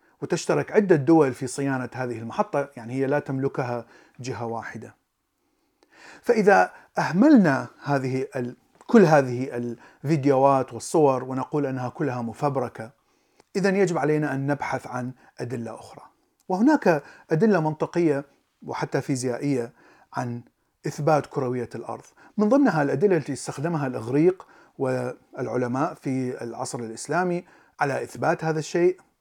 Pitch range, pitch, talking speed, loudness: 125-165 Hz, 140 Hz, 115 wpm, -24 LUFS